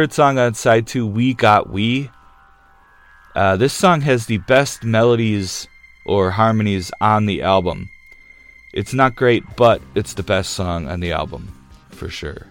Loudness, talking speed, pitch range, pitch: -17 LUFS, 155 wpm, 90-130 Hz, 105 Hz